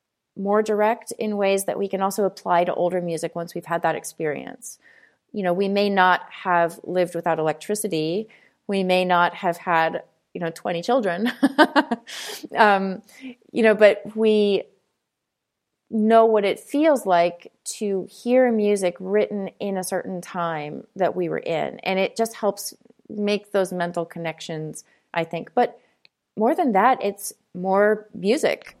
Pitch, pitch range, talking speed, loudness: 195 Hz, 175-215 Hz, 155 wpm, -22 LUFS